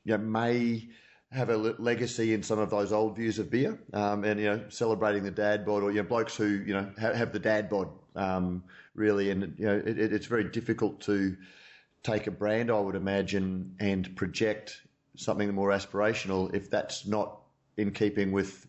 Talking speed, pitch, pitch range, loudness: 200 wpm, 105 Hz, 100-110 Hz, -30 LUFS